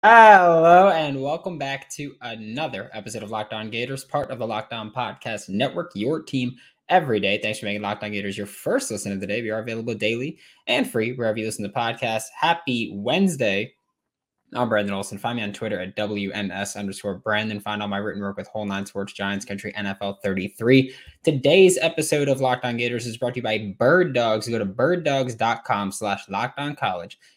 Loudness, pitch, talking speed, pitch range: -22 LUFS, 110 Hz, 185 wpm, 100-135 Hz